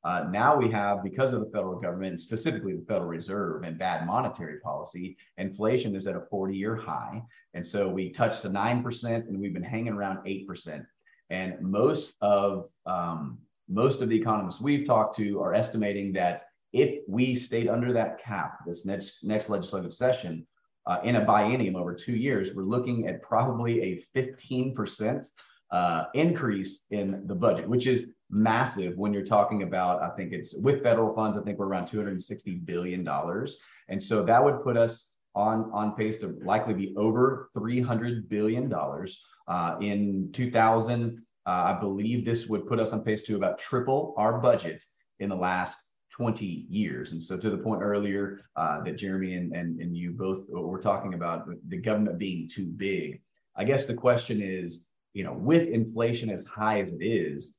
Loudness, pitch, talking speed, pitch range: -29 LUFS, 105 Hz, 180 wpm, 95-115 Hz